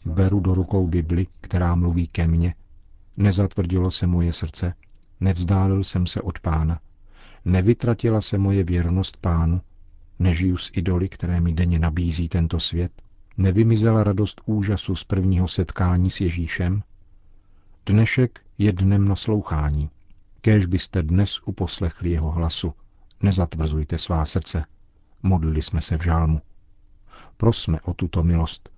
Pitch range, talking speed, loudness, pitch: 85-100 Hz, 125 wpm, -22 LUFS, 90 Hz